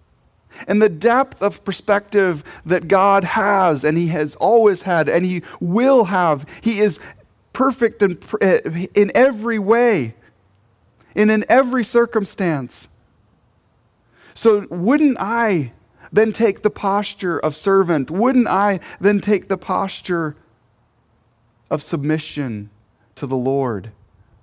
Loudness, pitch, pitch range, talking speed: -18 LUFS, 185 Hz, 145-215 Hz, 120 wpm